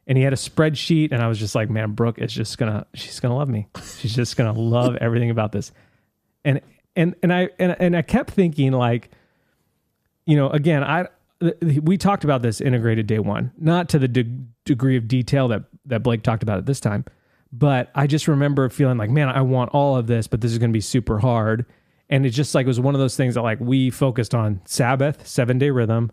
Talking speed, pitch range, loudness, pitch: 230 wpm, 115-145 Hz, -20 LUFS, 130 Hz